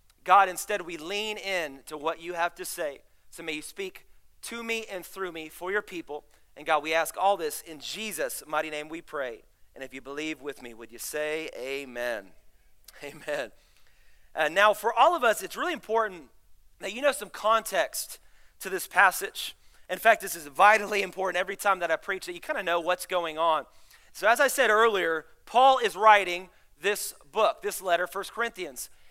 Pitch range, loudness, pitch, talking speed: 155-215 Hz, -27 LUFS, 180 Hz, 200 wpm